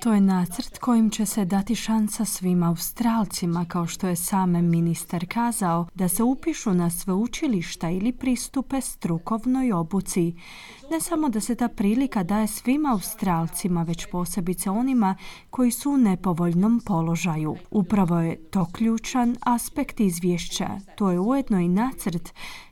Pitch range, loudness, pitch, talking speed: 175-235 Hz, -24 LUFS, 200 Hz, 145 wpm